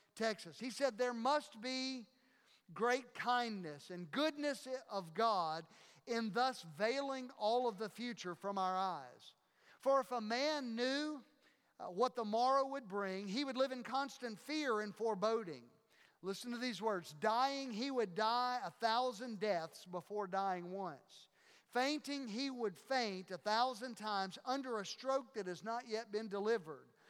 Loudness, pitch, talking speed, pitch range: -40 LUFS, 230 Hz, 155 wpm, 205-255 Hz